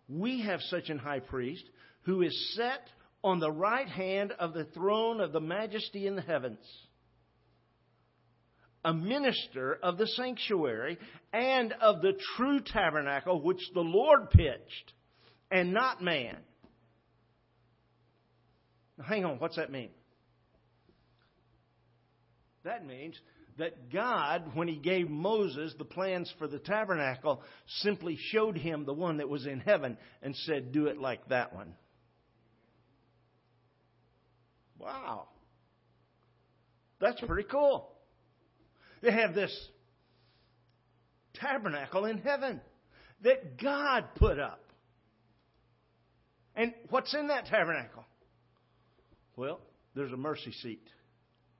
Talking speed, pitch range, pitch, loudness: 115 wpm, 125-215 Hz, 165 Hz, -32 LUFS